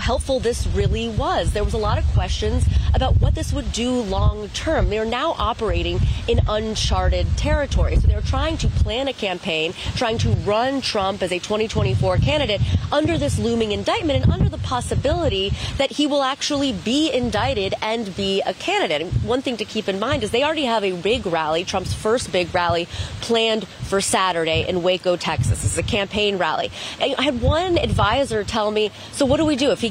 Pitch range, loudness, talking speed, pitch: 175-245 Hz, -21 LUFS, 195 wpm, 210 Hz